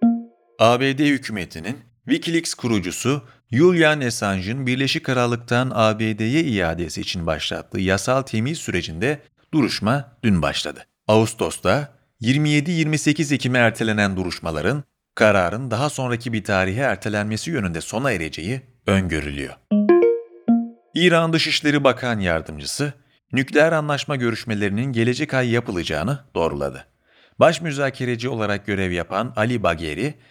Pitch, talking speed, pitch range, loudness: 120 Hz, 100 wpm, 105-145 Hz, -21 LUFS